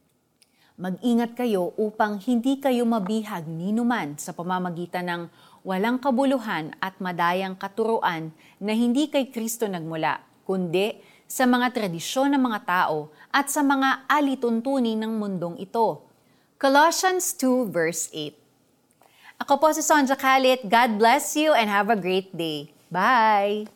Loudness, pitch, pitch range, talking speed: -23 LUFS, 220 Hz, 180-255 Hz, 130 wpm